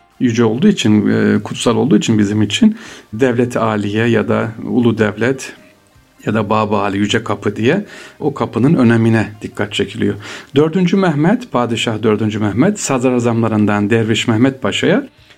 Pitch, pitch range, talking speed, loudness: 115 Hz, 105-125 Hz, 135 wpm, -15 LUFS